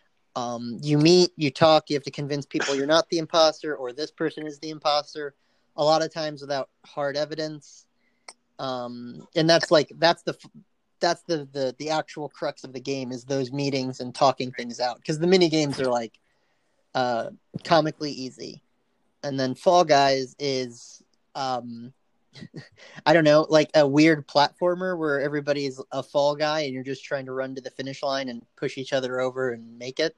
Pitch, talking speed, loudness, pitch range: 145 Hz, 185 wpm, -24 LUFS, 130-155 Hz